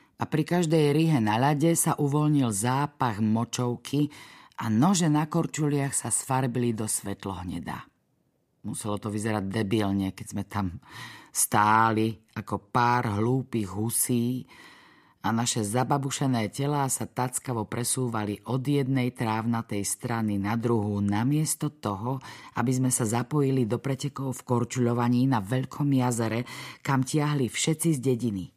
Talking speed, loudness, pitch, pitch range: 130 wpm, -27 LUFS, 120 Hz, 110-140 Hz